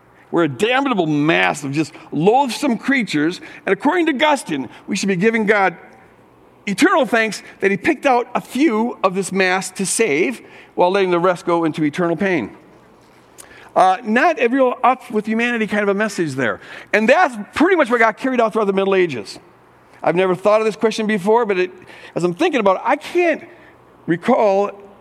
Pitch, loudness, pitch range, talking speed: 215 Hz, -17 LUFS, 185-245 Hz, 185 wpm